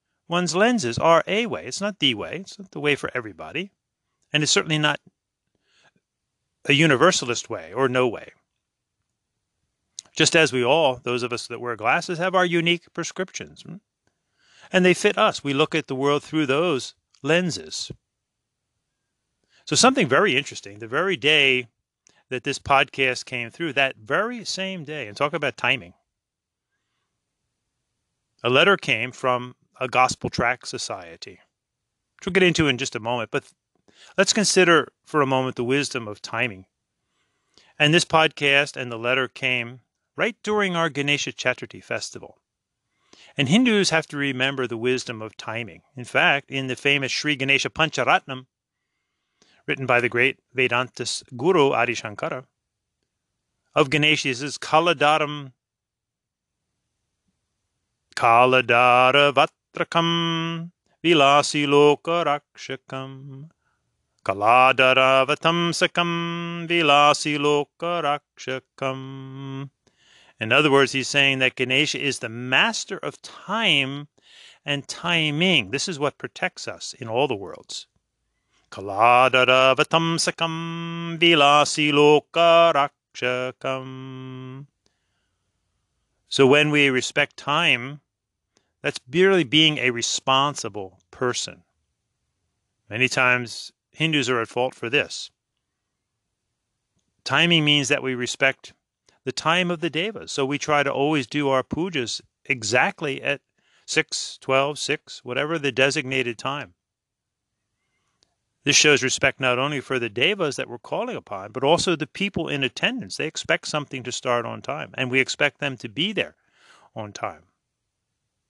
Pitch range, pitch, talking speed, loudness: 125-155 Hz, 135 Hz, 130 wpm, -21 LUFS